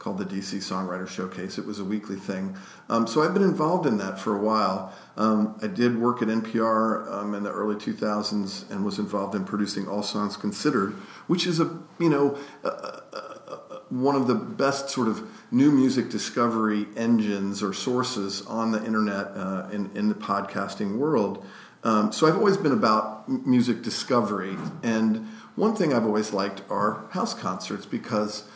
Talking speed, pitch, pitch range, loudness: 180 wpm, 110 Hz, 105-125 Hz, -26 LUFS